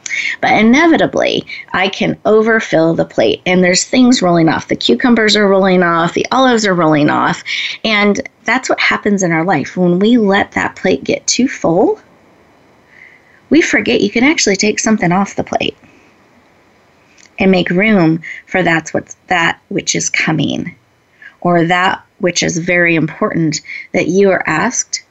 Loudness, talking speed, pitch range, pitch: -12 LUFS, 160 wpm, 175-220 Hz, 195 Hz